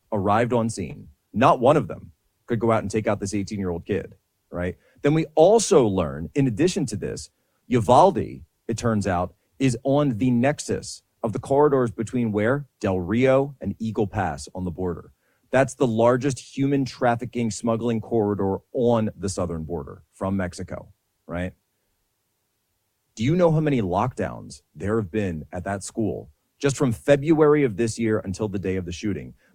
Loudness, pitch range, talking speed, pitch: -23 LUFS, 95-125 Hz, 175 wpm, 110 Hz